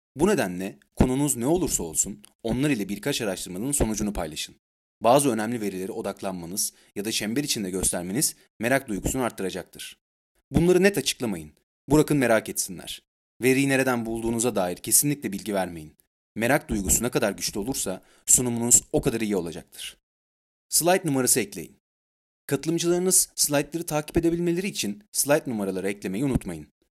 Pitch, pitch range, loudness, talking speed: 115 Hz, 95-145 Hz, -24 LUFS, 135 wpm